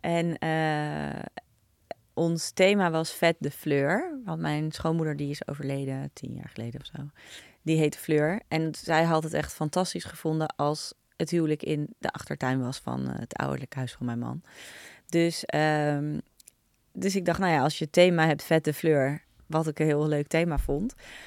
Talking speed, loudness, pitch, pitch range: 185 wpm, -28 LUFS, 155 Hz, 140-165 Hz